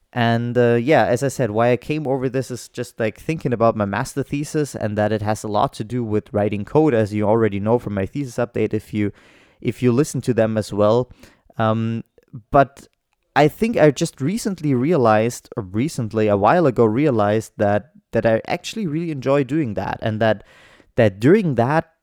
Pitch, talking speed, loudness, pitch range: 120 Hz, 200 wpm, -20 LUFS, 110-140 Hz